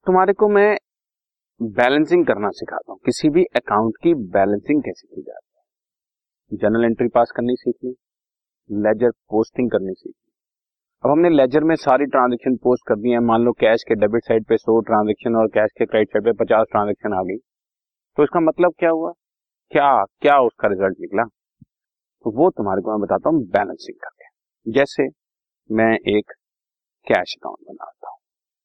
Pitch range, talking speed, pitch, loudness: 110-160 Hz, 165 wpm, 120 Hz, -18 LUFS